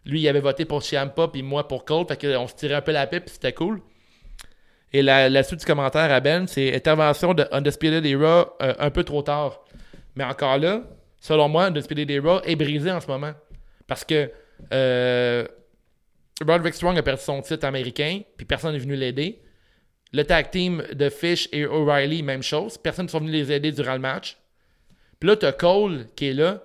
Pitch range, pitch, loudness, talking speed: 135-160 Hz, 145 Hz, -22 LUFS, 205 wpm